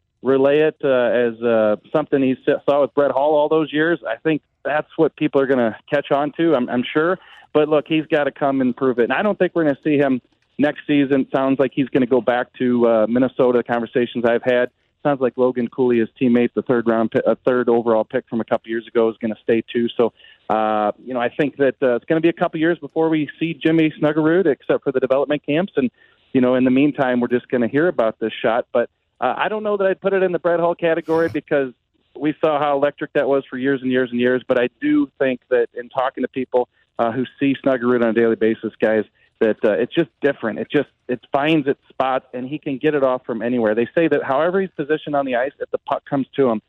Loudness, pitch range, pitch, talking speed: -19 LUFS, 120-155 Hz, 135 Hz, 260 wpm